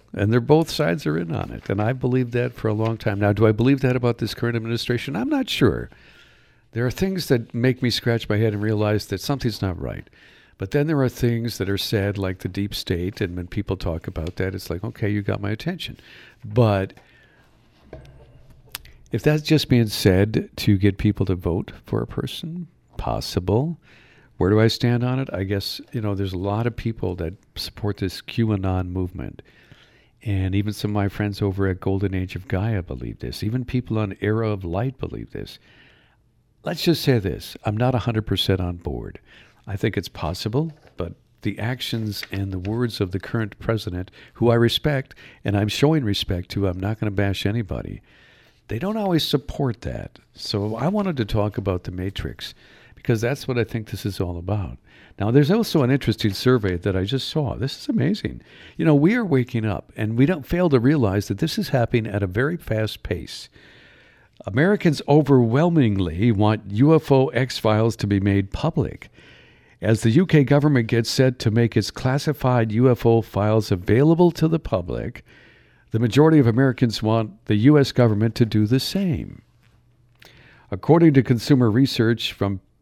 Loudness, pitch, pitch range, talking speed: -22 LUFS, 115 Hz, 100-130 Hz, 190 wpm